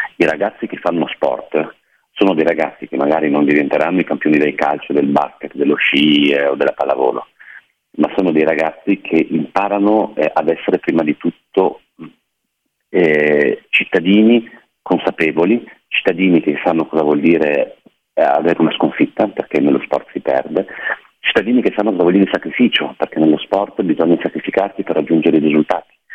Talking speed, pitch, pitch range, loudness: 160 wpm, 80 Hz, 75-95 Hz, -15 LUFS